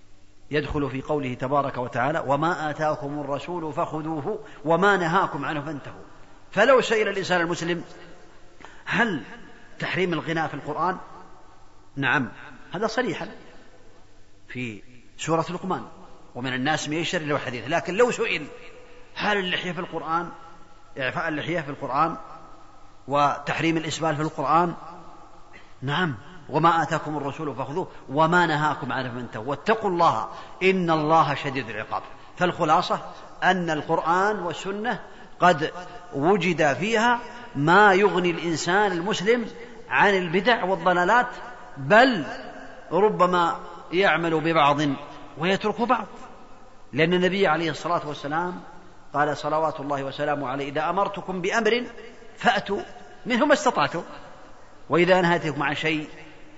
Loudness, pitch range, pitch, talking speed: -24 LUFS, 145-185 Hz, 160 Hz, 110 wpm